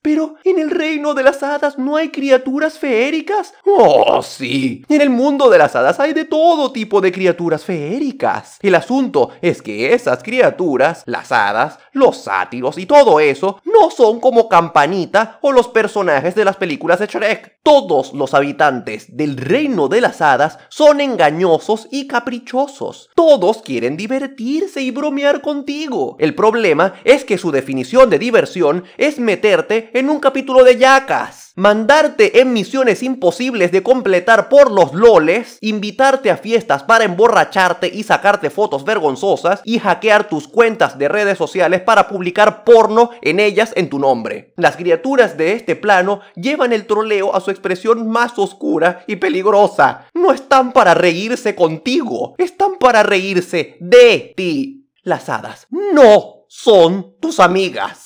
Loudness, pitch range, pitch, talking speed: -13 LUFS, 190-280 Hz, 230 Hz, 155 wpm